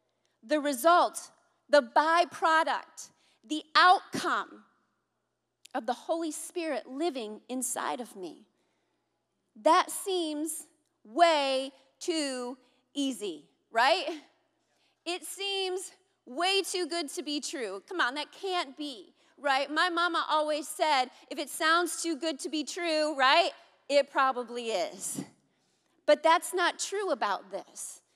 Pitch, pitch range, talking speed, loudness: 320 Hz, 285-345 Hz, 120 wpm, -29 LUFS